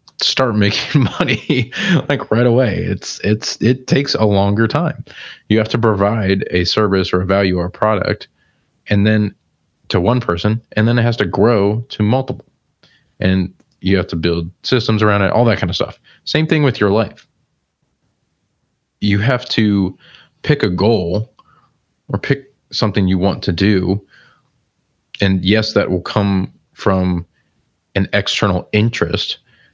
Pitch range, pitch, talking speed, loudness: 95-120 Hz, 105 Hz, 155 wpm, -16 LUFS